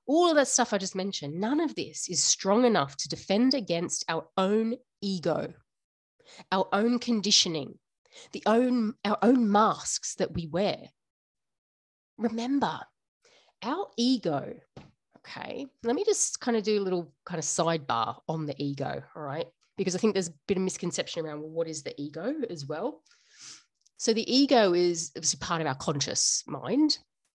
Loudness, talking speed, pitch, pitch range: -28 LUFS, 165 wpm, 195 Hz, 165-240 Hz